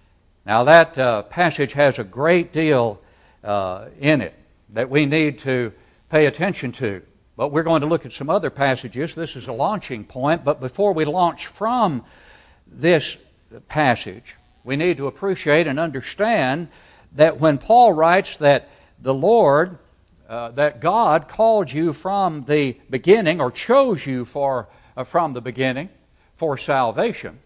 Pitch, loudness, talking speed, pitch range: 145 Hz, -19 LUFS, 155 wpm, 130-165 Hz